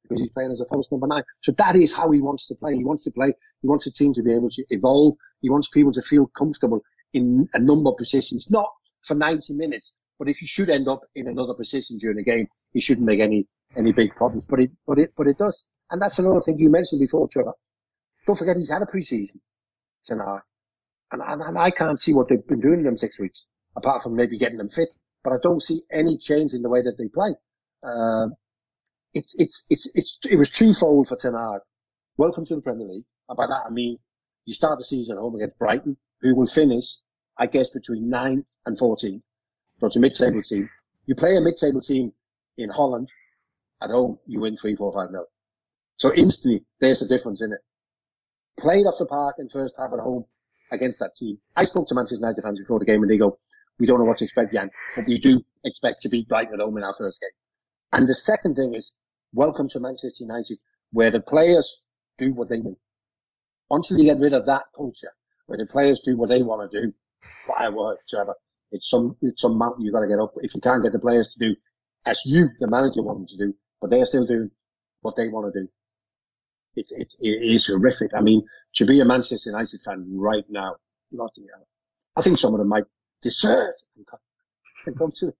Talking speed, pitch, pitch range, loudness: 230 wpm, 125 Hz, 110-145 Hz, -22 LUFS